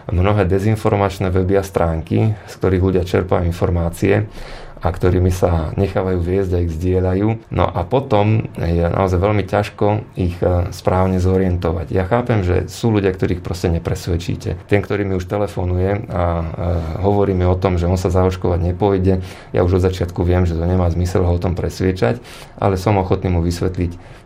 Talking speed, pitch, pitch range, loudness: 170 wpm, 95 Hz, 90-100 Hz, -18 LUFS